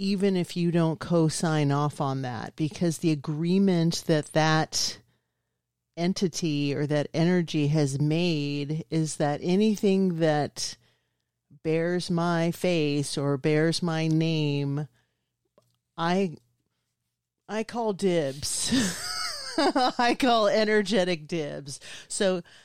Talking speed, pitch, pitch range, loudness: 105 wpm, 160 Hz, 145-180 Hz, -26 LUFS